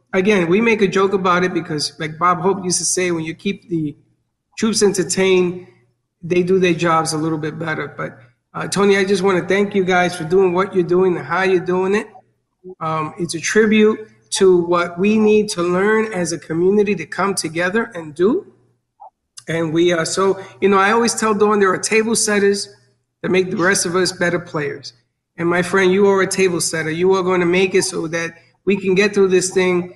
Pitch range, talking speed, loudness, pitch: 170-195 Hz, 220 wpm, -17 LUFS, 185 Hz